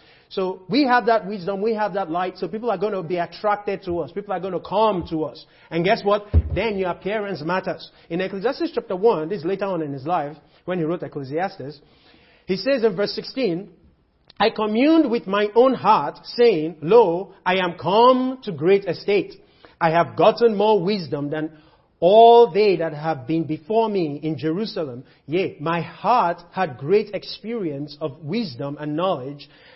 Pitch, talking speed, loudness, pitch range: 185 Hz, 185 wpm, -21 LUFS, 160-215 Hz